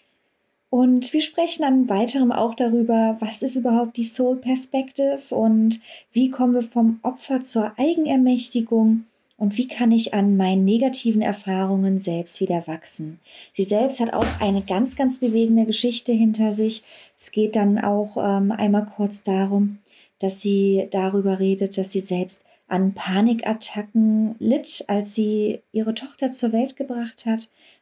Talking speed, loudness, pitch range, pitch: 145 wpm, -21 LUFS, 205-250 Hz, 225 Hz